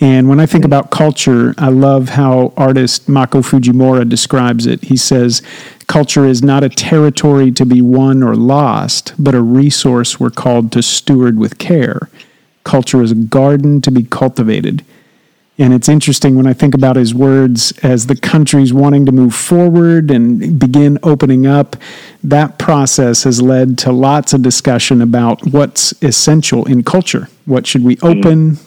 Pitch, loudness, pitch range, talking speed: 135 Hz, -9 LUFS, 125-145 Hz, 165 wpm